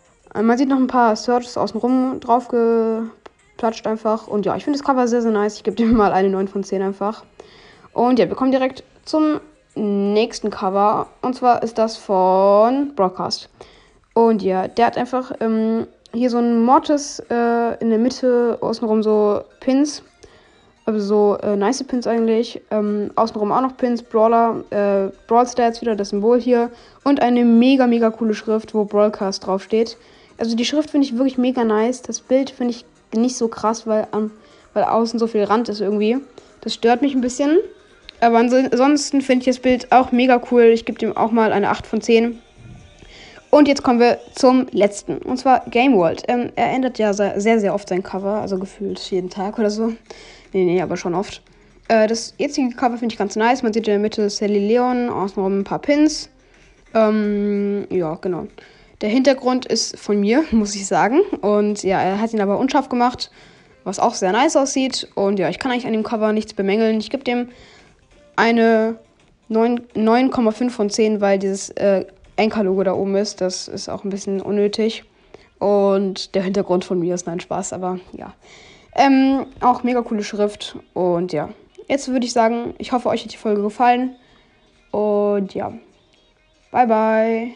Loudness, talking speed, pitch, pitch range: -18 LUFS, 185 wpm, 225 Hz, 205-245 Hz